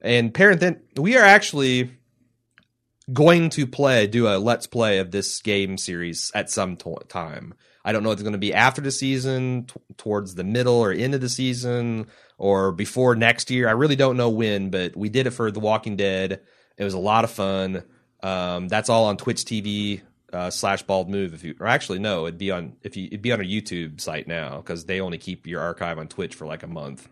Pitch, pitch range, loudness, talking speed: 110 Hz, 95-125 Hz, -22 LUFS, 225 wpm